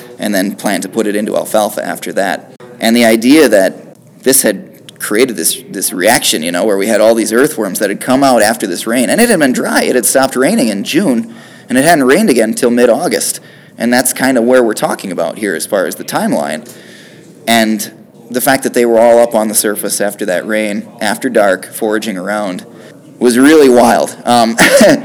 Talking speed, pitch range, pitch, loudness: 215 wpm, 110-125 Hz, 115 Hz, -11 LUFS